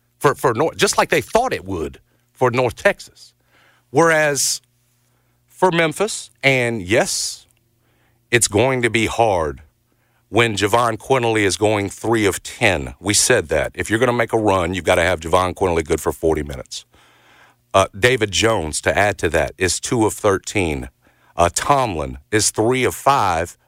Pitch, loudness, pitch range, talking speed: 115 Hz, -18 LUFS, 100-120 Hz, 170 wpm